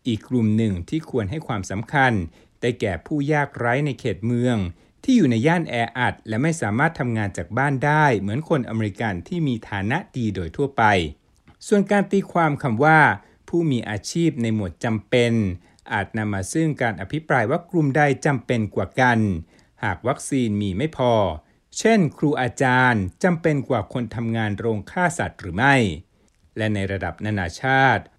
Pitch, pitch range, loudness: 120 Hz, 105-145 Hz, -22 LUFS